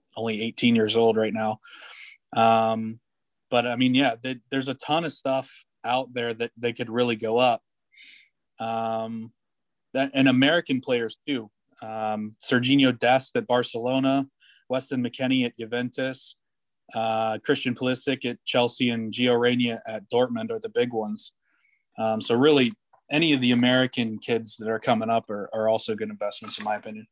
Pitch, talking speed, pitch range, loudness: 120 Hz, 165 wpm, 110-130 Hz, -25 LUFS